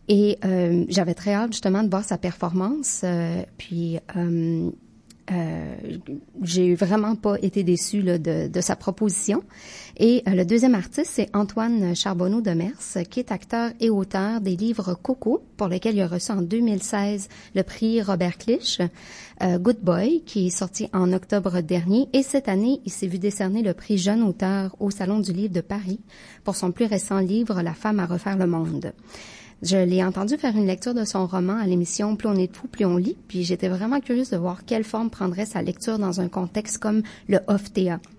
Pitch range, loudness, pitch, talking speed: 180-215 Hz, -24 LUFS, 195 Hz, 195 wpm